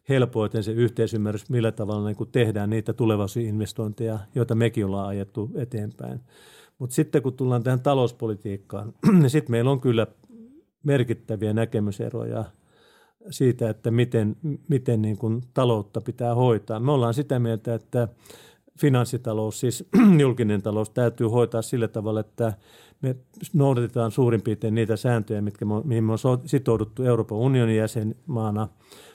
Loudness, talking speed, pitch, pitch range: -24 LUFS, 140 wpm, 115 Hz, 110-130 Hz